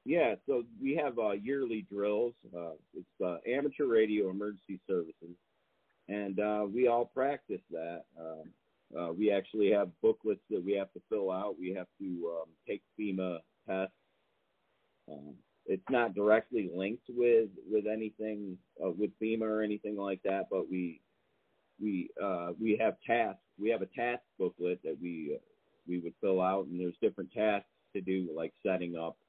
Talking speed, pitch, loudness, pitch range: 170 wpm, 100 Hz, -34 LUFS, 90-110 Hz